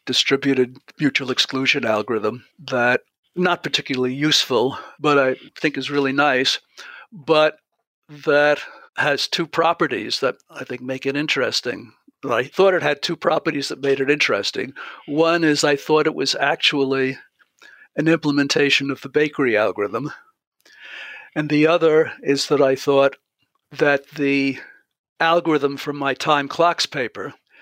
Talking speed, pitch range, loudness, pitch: 135 wpm, 135-155 Hz, -19 LUFS, 145 Hz